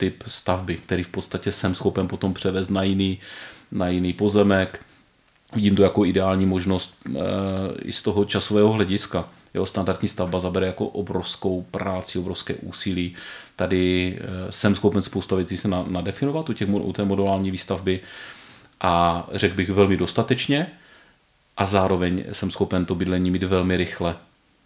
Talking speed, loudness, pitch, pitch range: 145 wpm, -23 LUFS, 95 Hz, 90-100 Hz